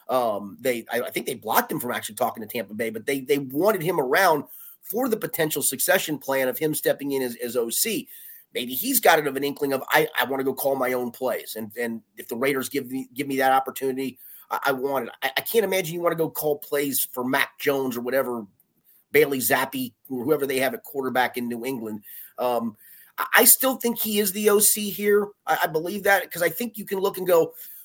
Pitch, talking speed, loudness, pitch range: 145 Hz, 240 wpm, -23 LUFS, 130-200 Hz